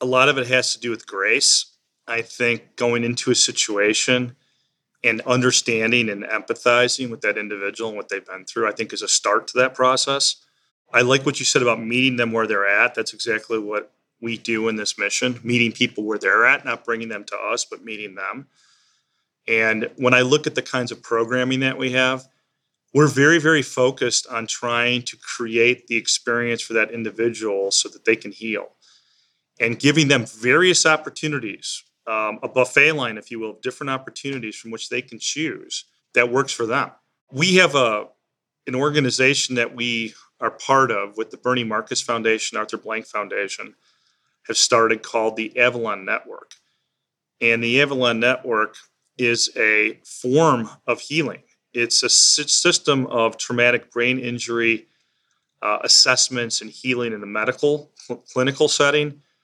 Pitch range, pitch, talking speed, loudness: 115-130 Hz, 120 Hz, 170 wpm, -19 LUFS